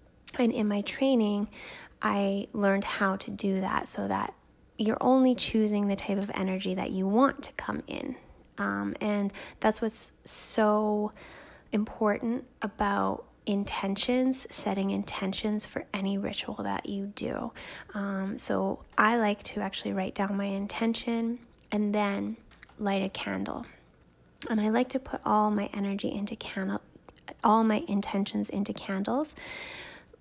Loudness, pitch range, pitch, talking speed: -29 LUFS, 195-230 Hz, 210 Hz, 140 wpm